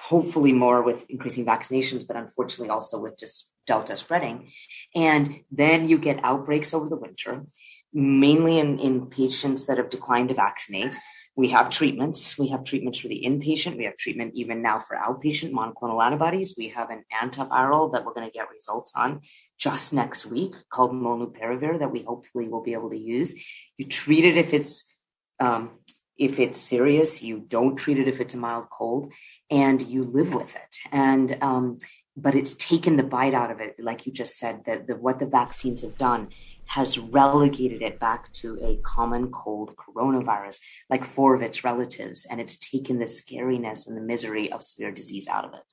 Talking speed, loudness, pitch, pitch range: 190 wpm, -24 LUFS, 130 Hz, 120-140 Hz